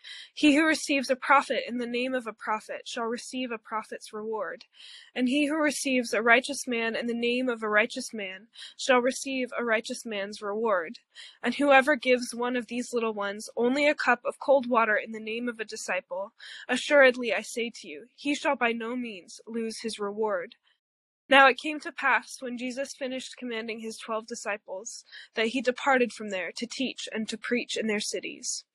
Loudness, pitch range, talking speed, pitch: -27 LUFS, 220-265 Hz, 195 wpm, 240 Hz